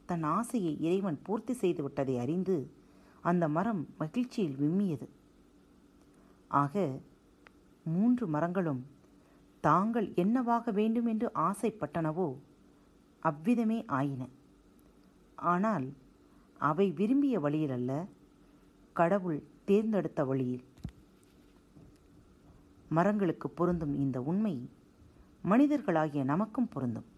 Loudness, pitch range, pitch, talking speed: -32 LUFS, 145-210 Hz, 170 Hz, 80 wpm